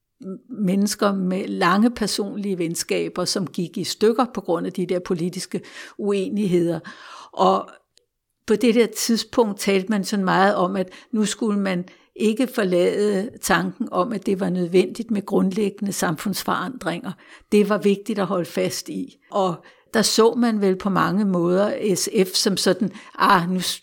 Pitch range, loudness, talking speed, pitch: 185-215 Hz, -21 LUFS, 155 wpm, 200 Hz